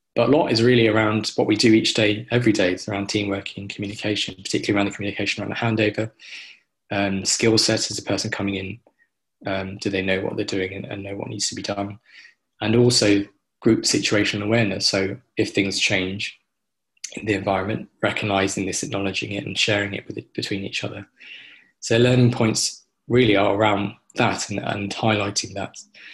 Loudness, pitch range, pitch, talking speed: -21 LUFS, 100-110 Hz, 100 Hz, 190 wpm